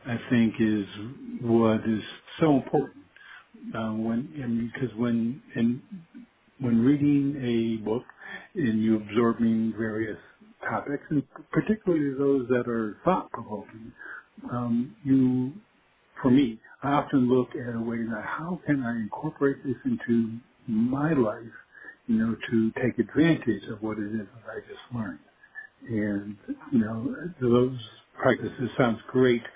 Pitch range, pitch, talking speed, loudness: 115-140 Hz, 120 Hz, 140 wpm, -27 LUFS